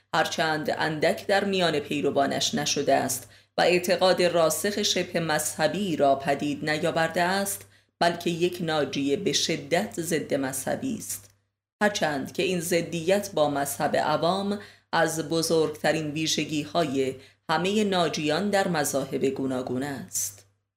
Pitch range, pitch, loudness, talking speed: 140-175 Hz, 160 Hz, -26 LUFS, 120 wpm